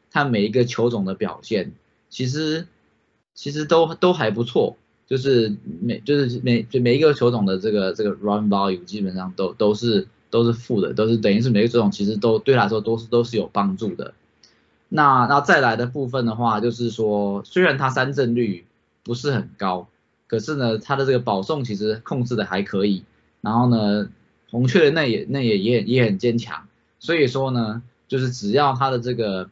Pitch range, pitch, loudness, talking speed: 105-130 Hz, 115 Hz, -21 LUFS, 285 characters per minute